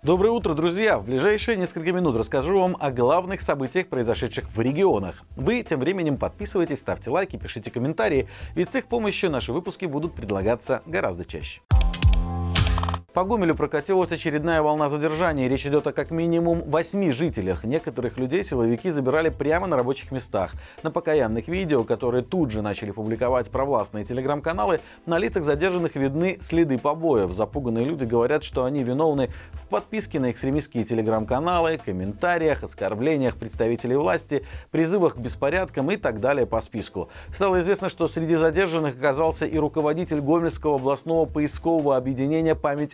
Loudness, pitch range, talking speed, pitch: -24 LUFS, 125-170 Hz, 150 wpm, 150 Hz